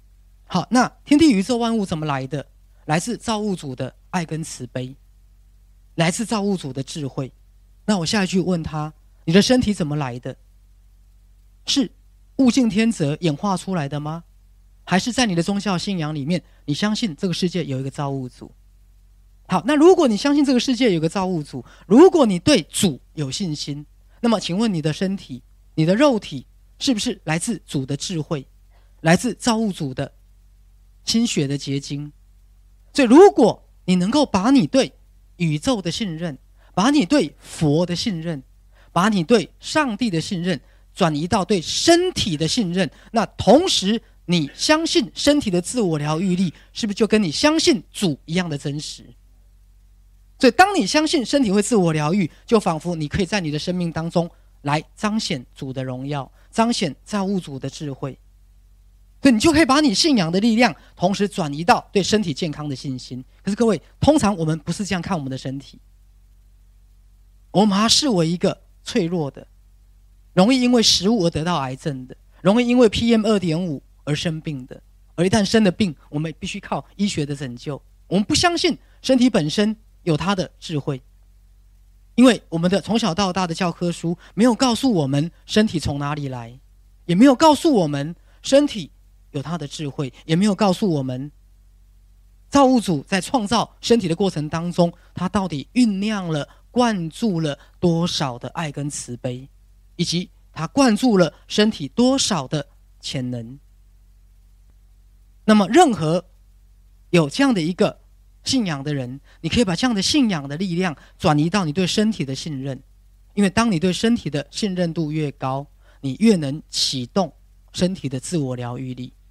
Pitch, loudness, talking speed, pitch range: 165 Hz, -20 LUFS, 250 characters per minute, 130-210 Hz